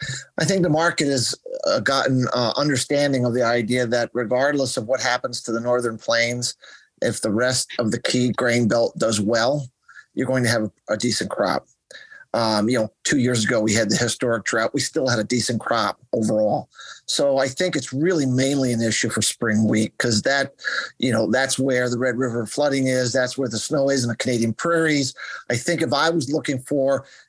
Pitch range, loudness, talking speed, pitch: 120-135 Hz, -21 LUFS, 205 wpm, 125 Hz